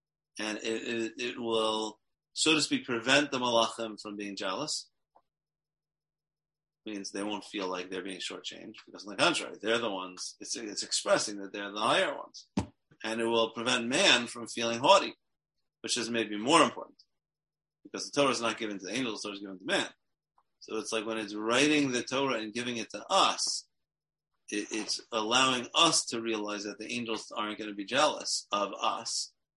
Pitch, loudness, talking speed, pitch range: 115 Hz, -30 LUFS, 190 wpm, 105-130 Hz